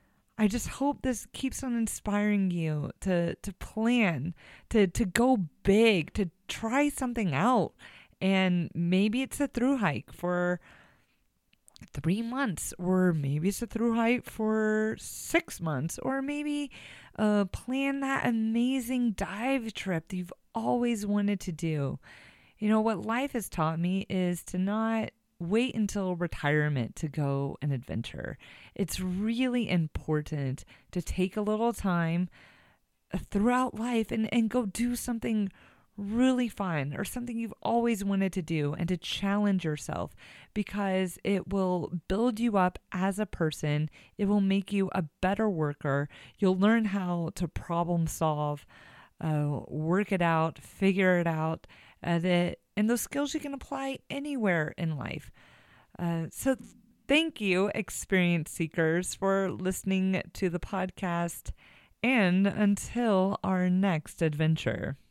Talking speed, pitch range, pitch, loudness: 140 wpm, 170-225 Hz, 195 Hz, -30 LUFS